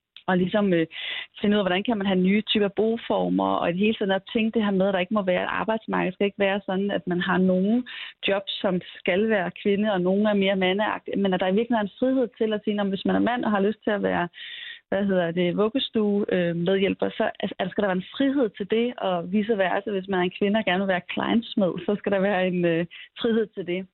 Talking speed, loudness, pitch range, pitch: 265 wpm, -24 LUFS, 185-220 Hz, 200 Hz